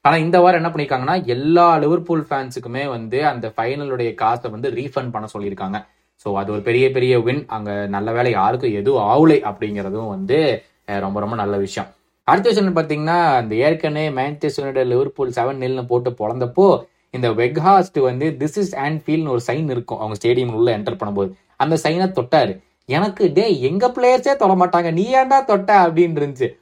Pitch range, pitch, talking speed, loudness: 120-170 Hz, 140 Hz, 165 wpm, -18 LUFS